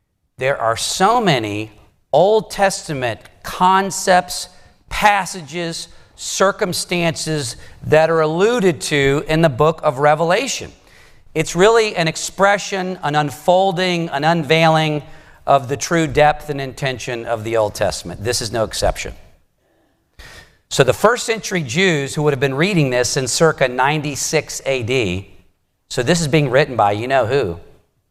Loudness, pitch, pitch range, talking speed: -17 LUFS, 155 Hz, 130-180 Hz, 135 wpm